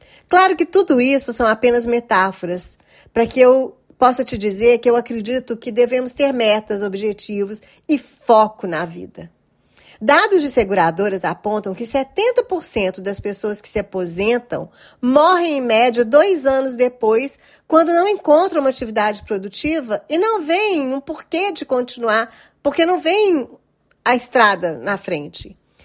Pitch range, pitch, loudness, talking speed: 215-300 Hz, 245 Hz, -17 LUFS, 145 wpm